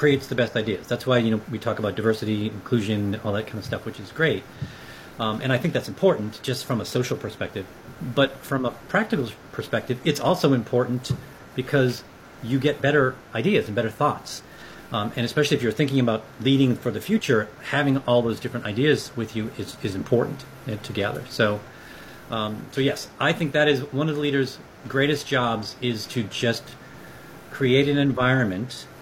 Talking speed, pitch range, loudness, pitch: 190 wpm, 110-135 Hz, -24 LUFS, 125 Hz